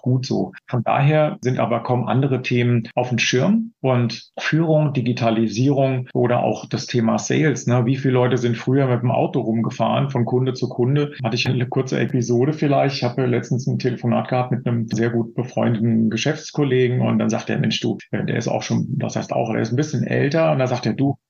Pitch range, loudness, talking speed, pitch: 120-135 Hz, -20 LUFS, 210 wpm, 125 Hz